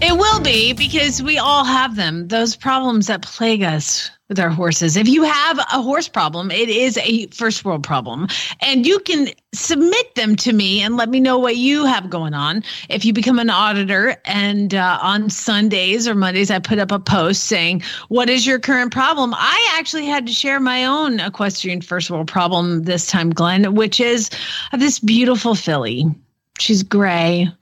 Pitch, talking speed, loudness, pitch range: 220 Hz, 190 wpm, -16 LUFS, 185-255 Hz